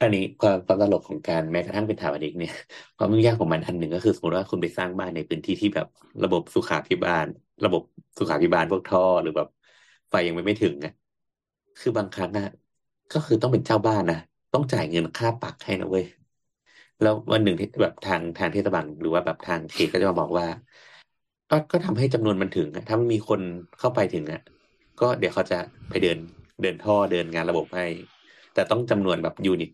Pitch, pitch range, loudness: 100 Hz, 85-110 Hz, -25 LUFS